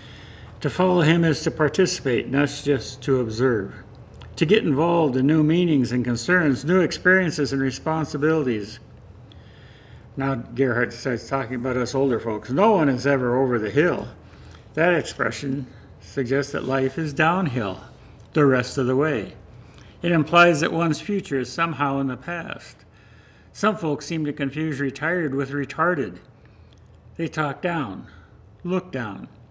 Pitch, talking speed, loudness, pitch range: 140 Hz, 145 wpm, -22 LUFS, 120-160 Hz